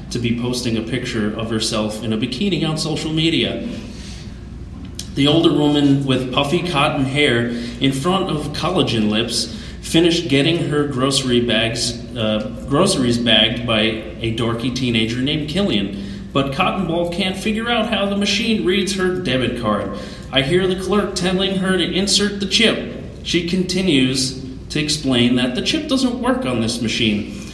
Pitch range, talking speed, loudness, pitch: 115-180 Hz, 160 wpm, -18 LUFS, 135 Hz